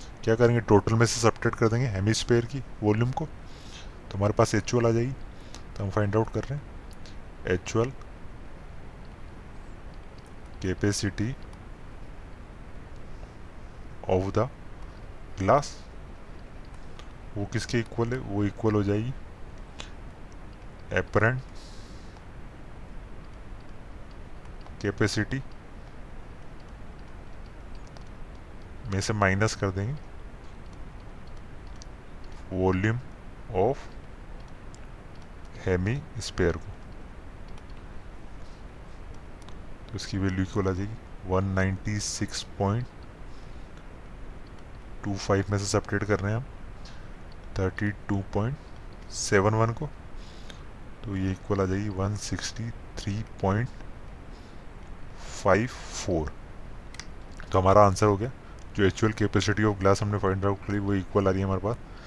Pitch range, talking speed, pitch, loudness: 95-110 Hz, 100 wpm, 100 Hz, -27 LUFS